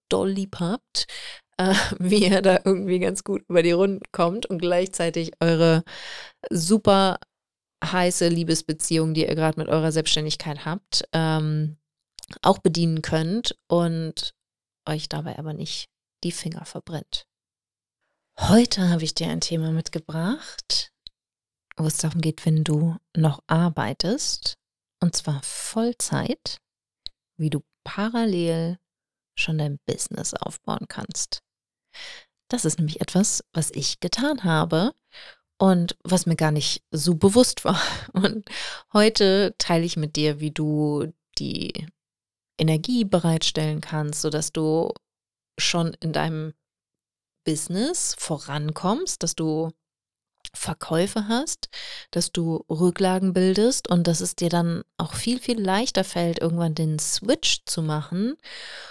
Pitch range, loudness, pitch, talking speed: 155-190 Hz, -24 LUFS, 170 Hz, 125 wpm